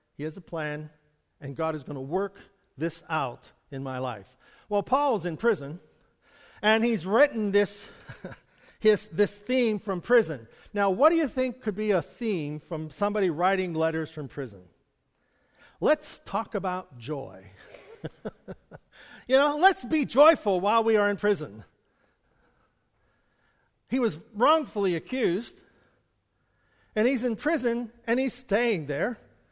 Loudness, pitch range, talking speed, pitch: -27 LUFS, 155-235 Hz, 140 wpm, 200 Hz